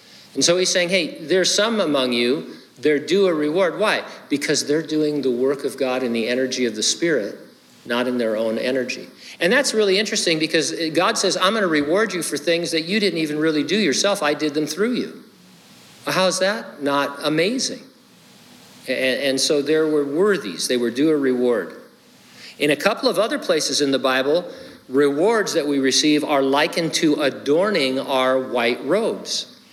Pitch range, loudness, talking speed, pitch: 135-190 Hz, -20 LUFS, 190 wpm, 150 Hz